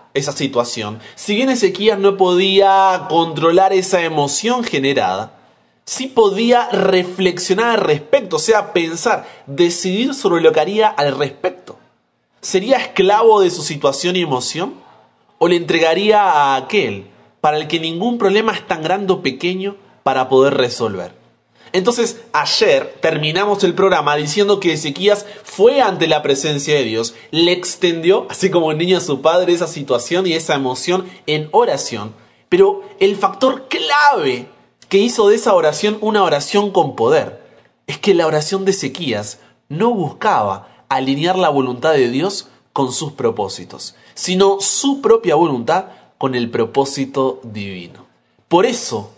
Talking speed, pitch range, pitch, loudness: 150 wpm, 150-210 Hz, 180 Hz, -15 LUFS